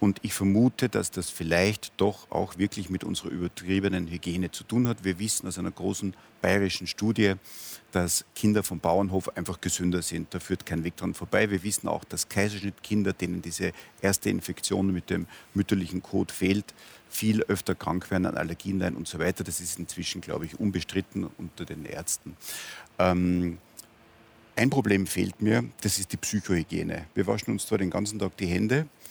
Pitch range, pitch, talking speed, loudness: 90-105 Hz, 95 Hz, 175 wpm, -28 LUFS